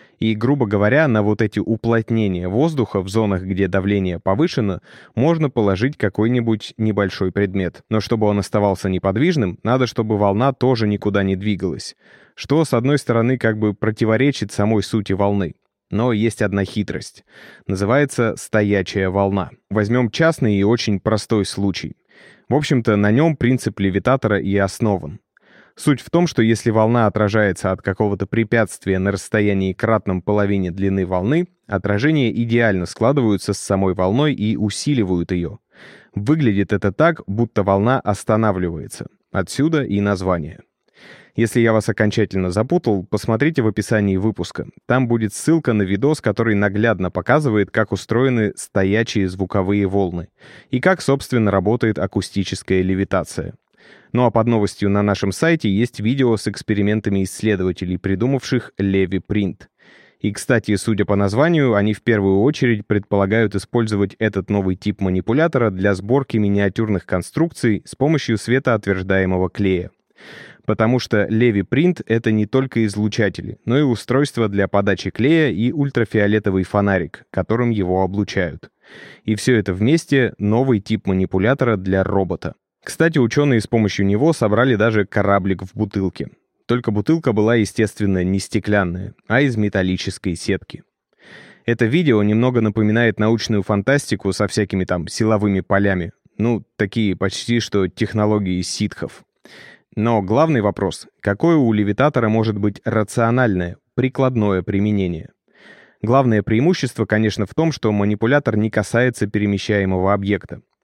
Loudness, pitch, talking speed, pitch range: -18 LUFS, 105 Hz, 135 wpm, 100-120 Hz